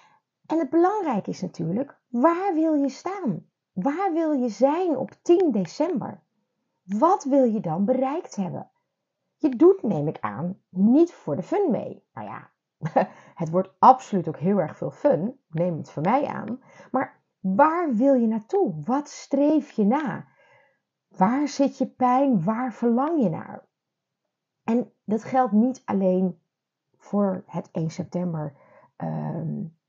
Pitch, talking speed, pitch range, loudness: 245 Hz, 150 wpm, 185-285 Hz, -24 LUFS